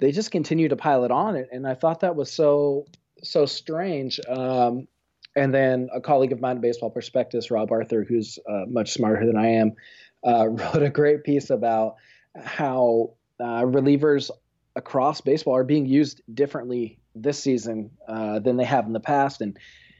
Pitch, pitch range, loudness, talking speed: 130 Hz, 115-145 Hz, -23 LUFS, 175 wpm